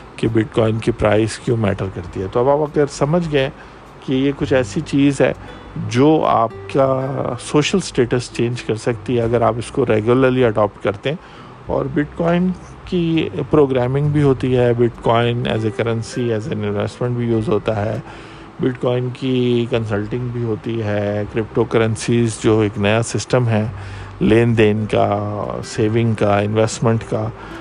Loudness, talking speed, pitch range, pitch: -18 LUFS, 170 wpm, 110-130 Hz, 120 Hz